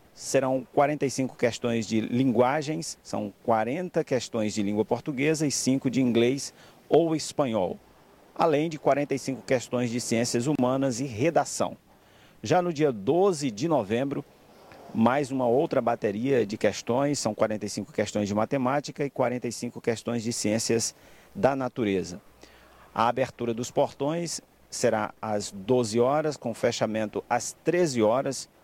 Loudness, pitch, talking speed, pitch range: -27 LUFS, 125 Hz, 130 wpm, 115-145 Hz